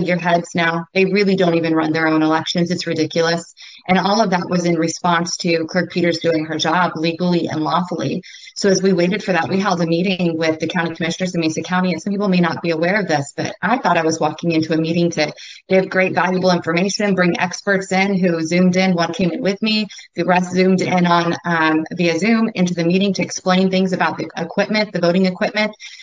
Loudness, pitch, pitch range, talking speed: -17 LUFS, 175 Hz, 165-185 Hz, 230 wpm